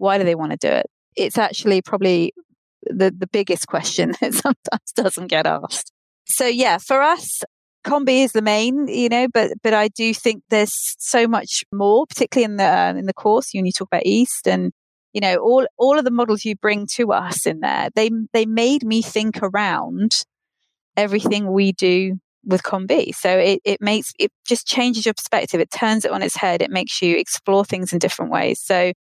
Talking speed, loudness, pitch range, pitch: 205 wpm, -19 LUFS, 190-240 Hz, 215 Hz